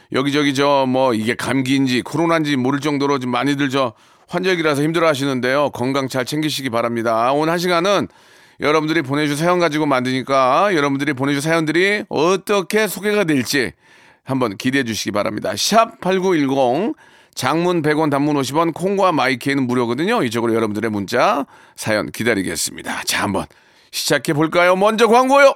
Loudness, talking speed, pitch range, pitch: -17 LUFS, 375 characters per minute, 130-170 Hz, 145 Hz